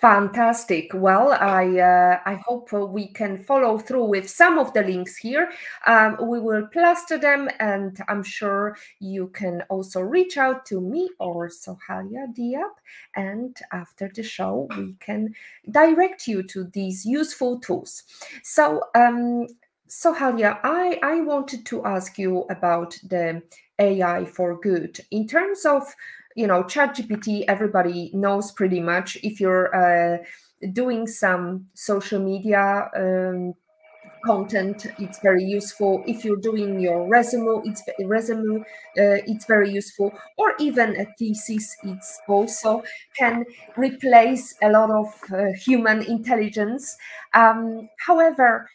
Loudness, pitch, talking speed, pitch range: -21 LUFS, 210 Hz, 135 wpm, 195-240 Hz